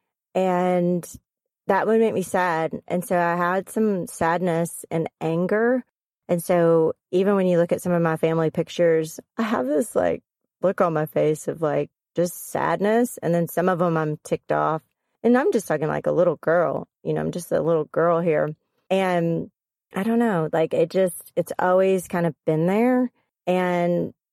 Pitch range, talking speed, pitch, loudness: 165-190 Hz, 185 wpm, 175 Hz, -23 LUFS